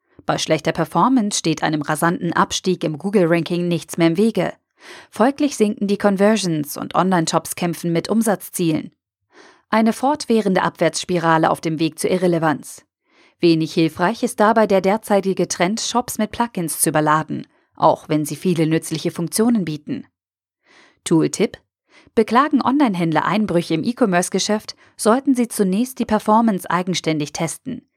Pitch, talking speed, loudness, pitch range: 180 Hz, 135 wpm, -19 LUFS, 165-220 Hz